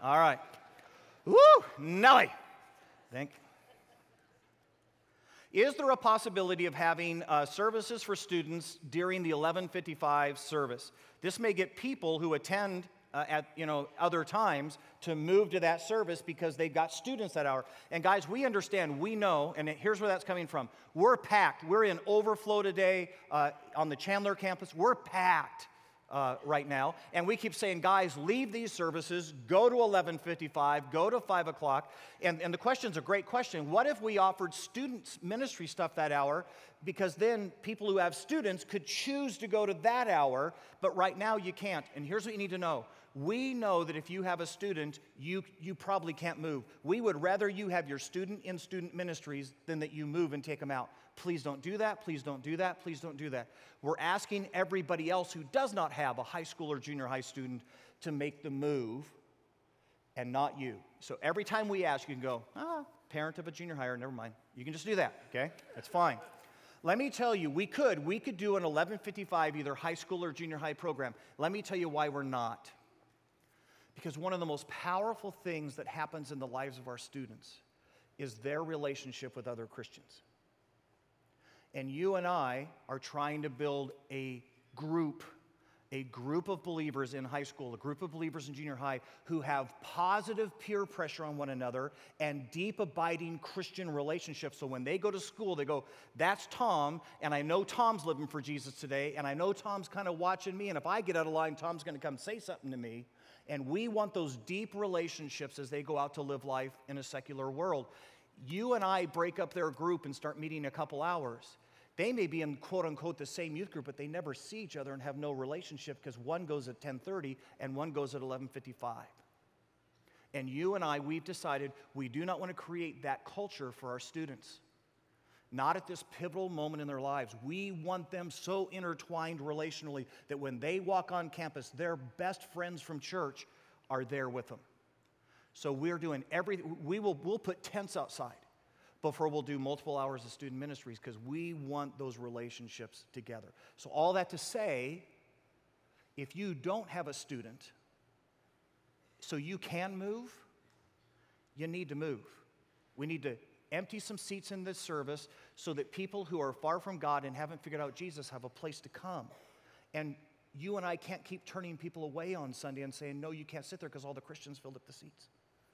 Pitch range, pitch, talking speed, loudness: 140-185 Hz, 160 Hz, 195 wpm, -36 LUFS